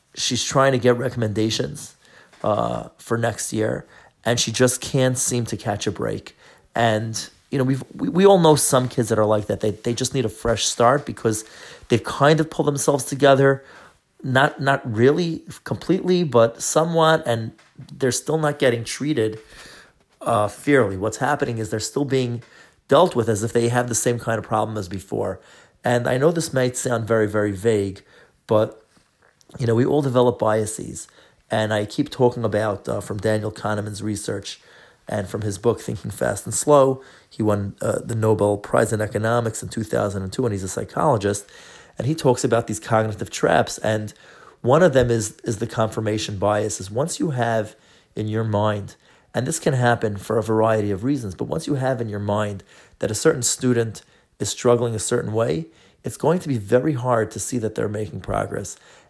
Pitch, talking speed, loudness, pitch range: 115 Hz, 195 wpm, -21 LUFS, 110-130 Hz